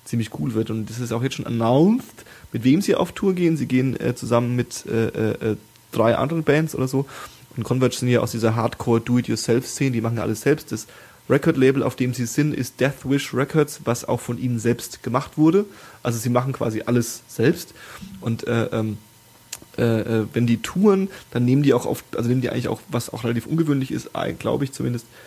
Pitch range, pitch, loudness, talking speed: 115-140 Hz, 125 Hz, -22 LUFS, 205 wpm